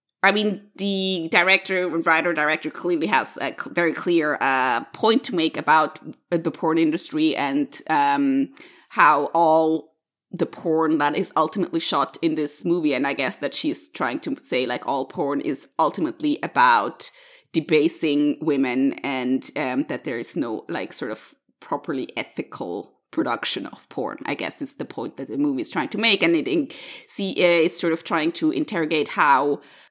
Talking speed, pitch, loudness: 170 wpm, 175 Hz, -22 LUFS